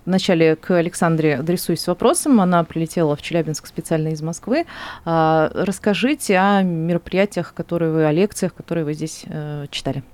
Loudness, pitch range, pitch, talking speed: -19 LUFS, 160-185 Hz, 170 Hz, 135 wpm